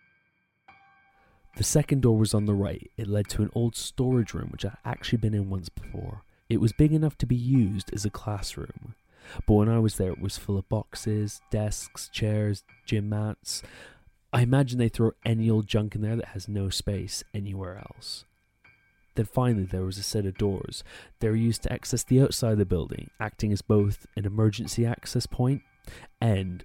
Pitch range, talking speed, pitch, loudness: 100-115 Hz, 195 wpm, 110 Hz, -27 LUFS